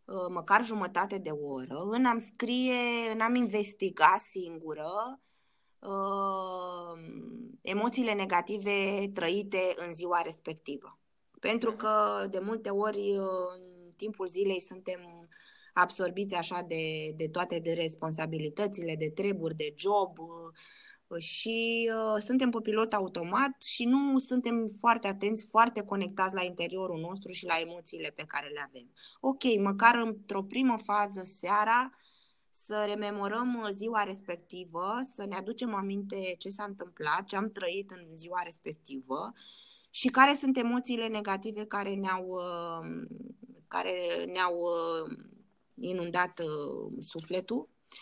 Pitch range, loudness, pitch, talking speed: 175-225 Hz, -32 LUFS, 195 Hz, 125 wpm